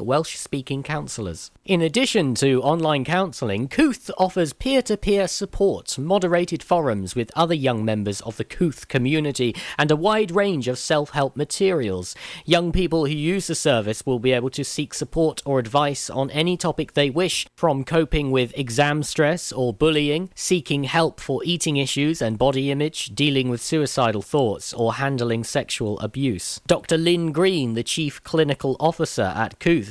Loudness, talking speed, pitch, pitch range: -22 LUFS, 160 wpm, 145 Hz, 130-170 Hz